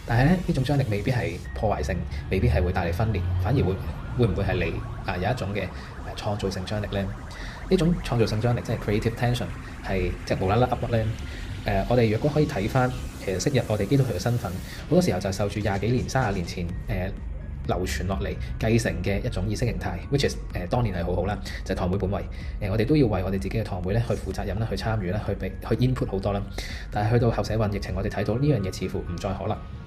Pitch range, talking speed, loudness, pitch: 95-115 Hz, 405 characters per minute, -26 LUFS, 100 Hz